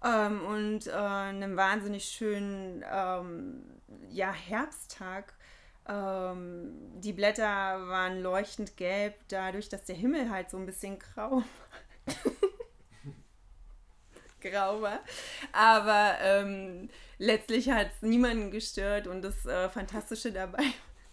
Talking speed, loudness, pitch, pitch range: 110 wpm, -31 LUFS, 205 Hz, 190-225 Hz